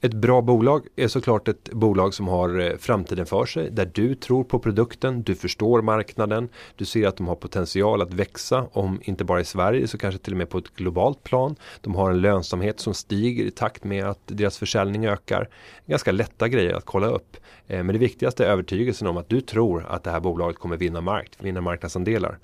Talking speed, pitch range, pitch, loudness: 210 wpm, 90-115 Hz, 100 Hz, -24 LUFS